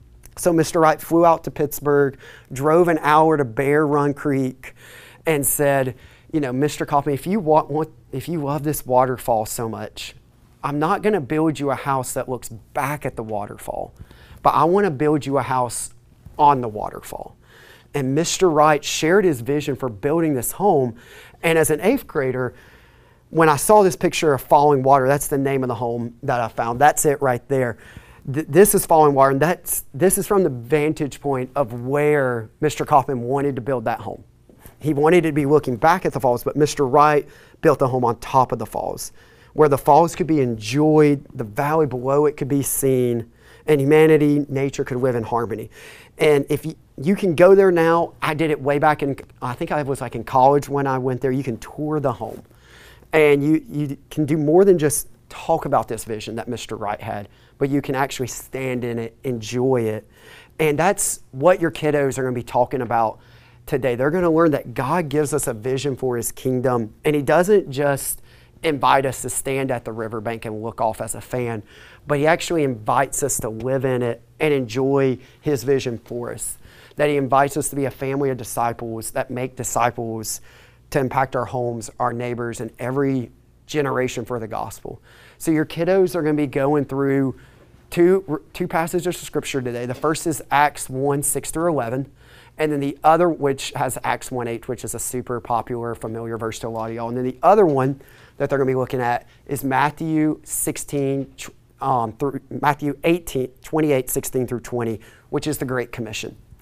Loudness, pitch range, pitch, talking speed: -20 LUFS, 120-150 Hz, 135 Hz, 205 wpm